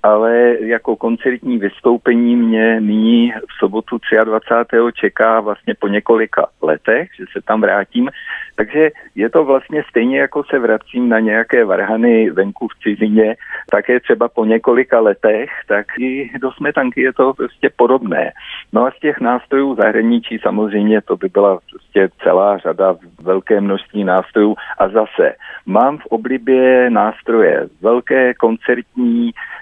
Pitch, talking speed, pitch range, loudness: 115 Hz, 140 wpm, 110-130 Hz, -14 LUFS